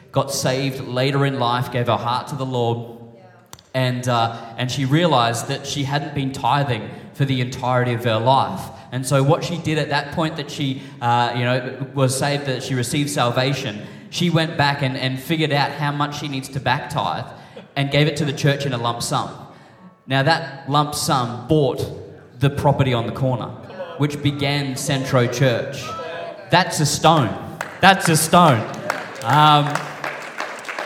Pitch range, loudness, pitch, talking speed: 125-150 Hz, -20 LUFS, 140 Hz, 175 wpm